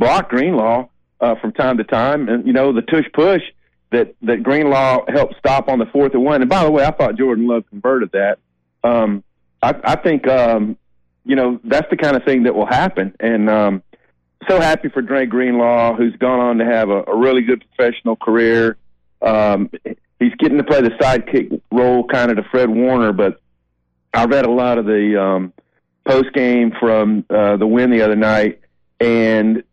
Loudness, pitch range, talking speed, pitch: -15 LUFS, 100-125 Hz, 195 wpm, 115 Hz